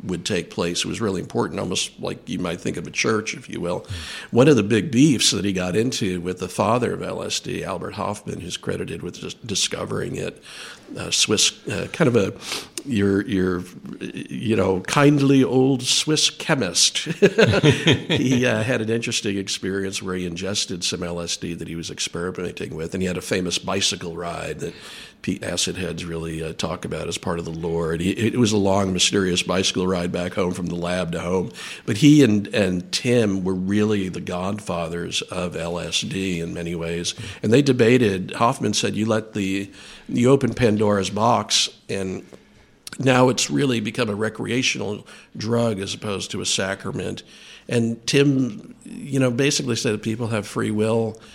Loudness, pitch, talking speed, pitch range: -21 LUFS, 100 Hz, 180 wpm, 90-120 Hz